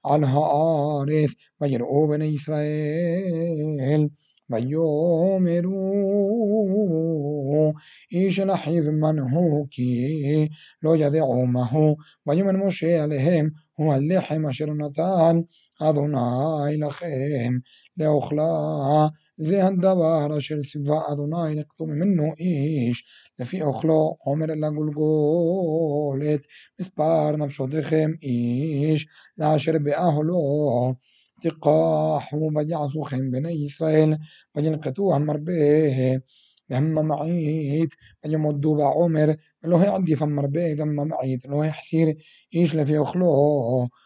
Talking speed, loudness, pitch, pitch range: 90 wpm, -23 LUFS, 155 Hz, 145-160 Hz